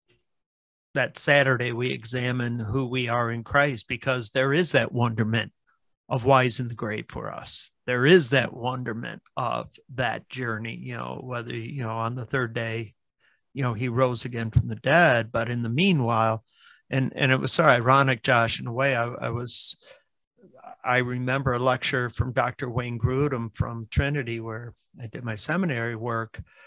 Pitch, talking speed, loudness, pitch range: 125 Hz, 175 wpm, -25 LUFS, 115-130 Hz